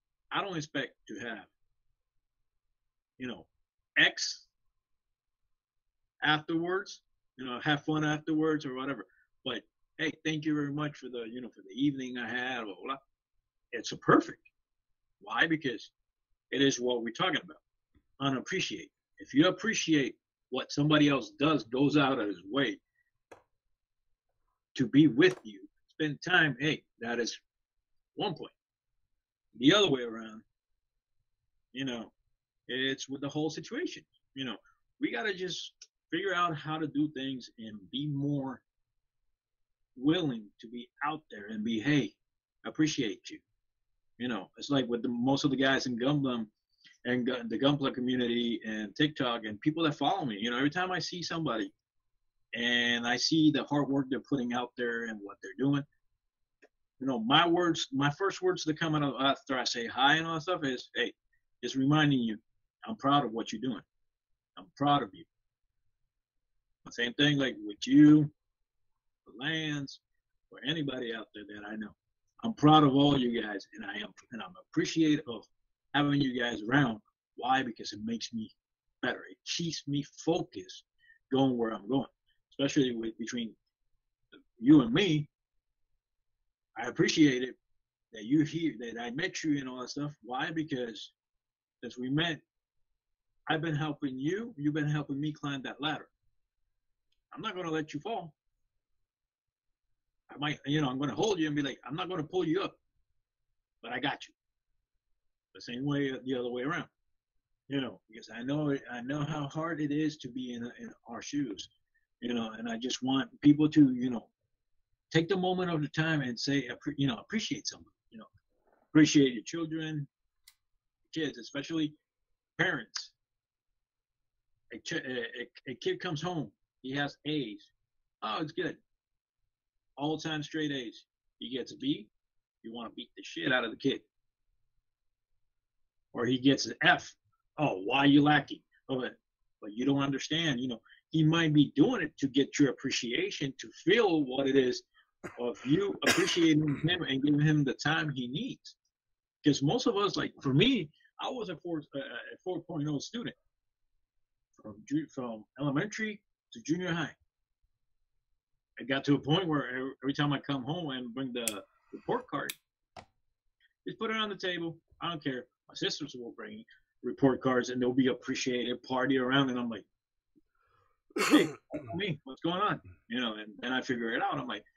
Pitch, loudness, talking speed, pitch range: 145 Hz, -31 LUFS, 170 wpm, 125-160 Hz